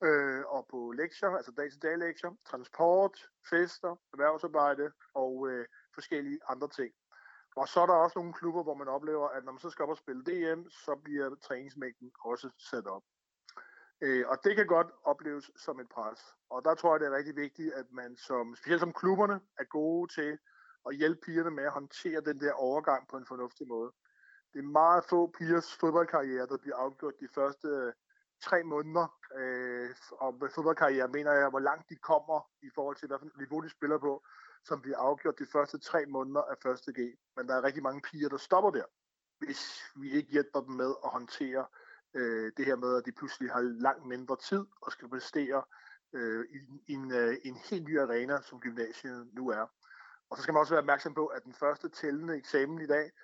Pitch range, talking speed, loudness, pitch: 130-165 Hz, 200 wpm, -33 LUFS, 145 Hz